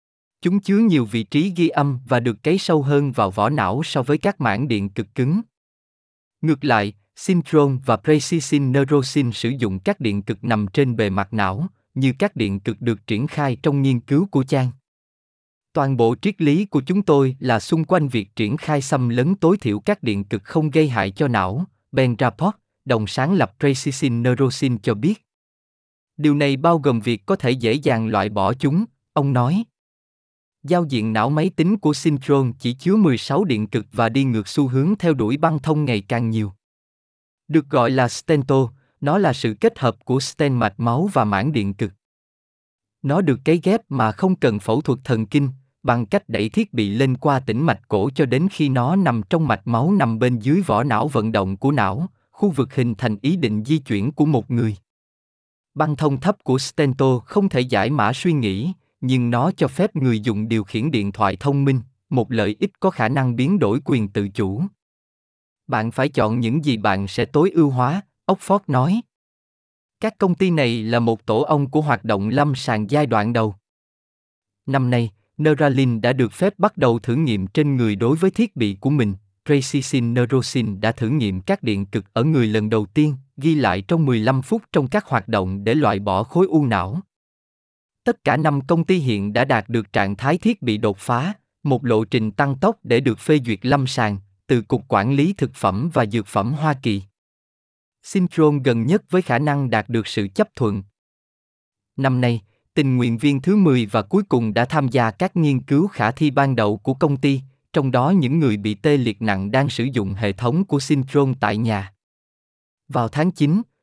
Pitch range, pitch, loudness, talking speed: 110-155 Hz, 130 Hz, -20 LUFS, 205 wpm